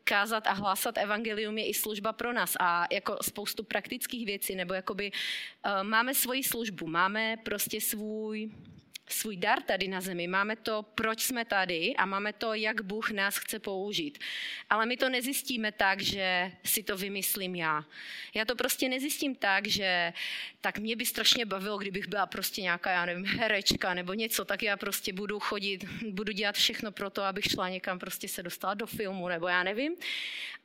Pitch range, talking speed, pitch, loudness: 195-225 Hz, 180 wpm, 205 Hz, -31 LUFS